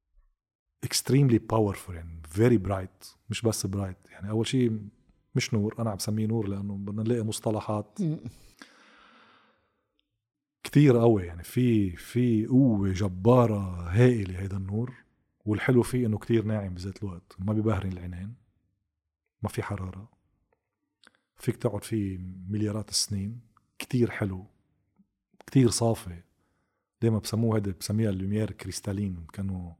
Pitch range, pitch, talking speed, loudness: 95-115 Hz, 105 Hz, 120 wpm, -28 LUFS